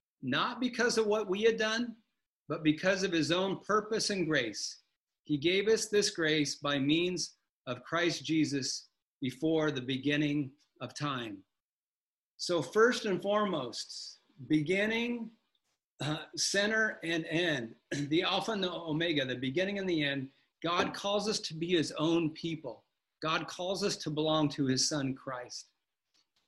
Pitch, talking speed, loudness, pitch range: 165 Hz, 150 wpm, -32 LUFS, 150-200 Hz